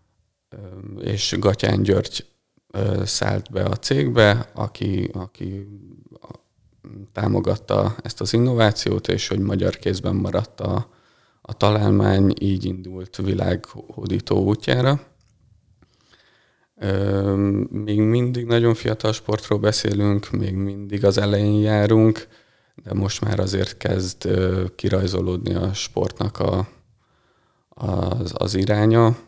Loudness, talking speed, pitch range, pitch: -21 LUFS, 100 wpm, 95-110 Hz, 100 Hz